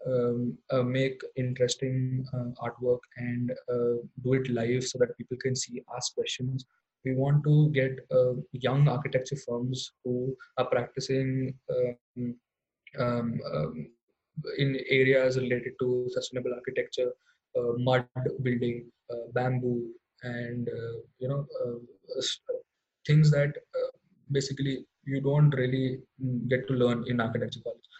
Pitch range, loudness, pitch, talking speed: 120-135 Hz, -30 LUFS, 130 Hz, 130 wpm